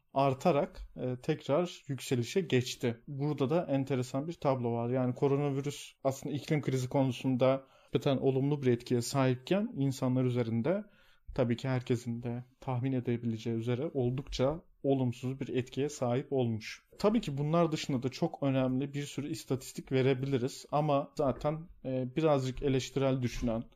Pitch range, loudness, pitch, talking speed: 125-145 Hz, -33 LUFS, 135 Hz, 130 wpm